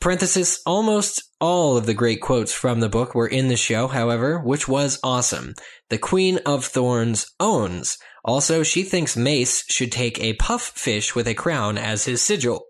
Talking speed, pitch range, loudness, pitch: 180 wpm, 115-175 Hz, -21 LUFS, 130 Hz